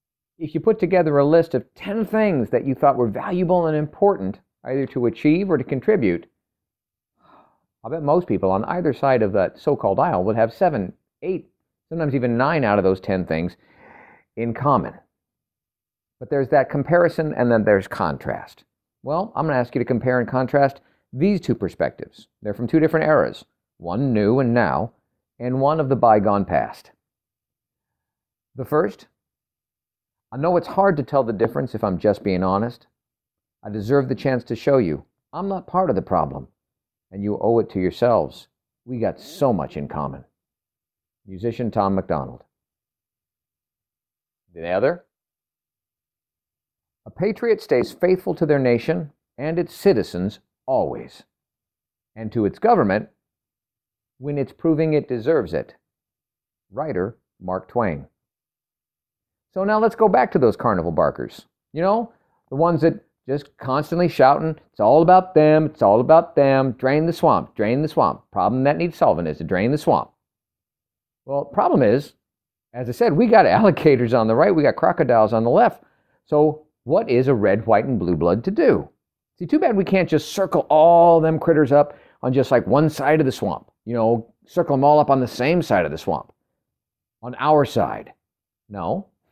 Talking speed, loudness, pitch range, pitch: 175 wpm, -20 LUFS, 115-160 Hz, 135 Hz